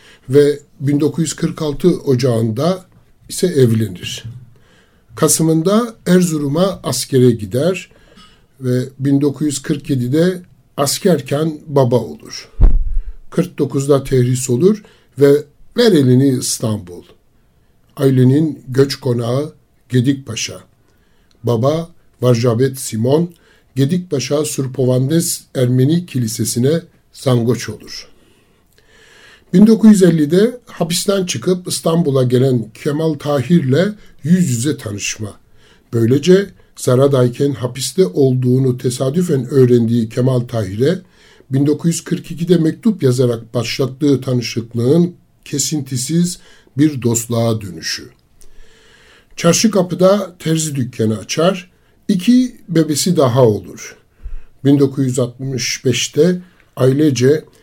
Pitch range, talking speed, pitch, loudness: 125-165 Hz, 75 wpm, 140 Hz, -15 LUFS